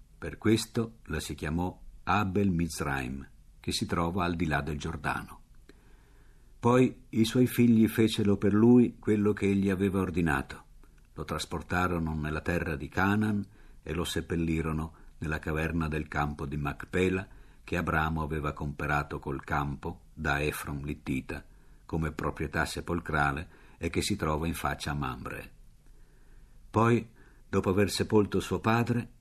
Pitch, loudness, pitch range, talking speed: 85 Hz, -30 LUFS, 75-105 Hz, 140 wpm